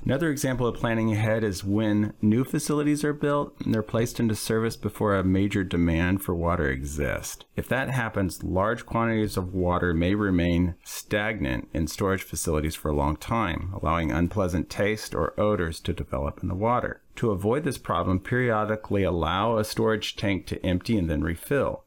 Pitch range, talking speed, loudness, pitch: 85-115 Hz, 175 wpm, -26 LUFS, 100 Hz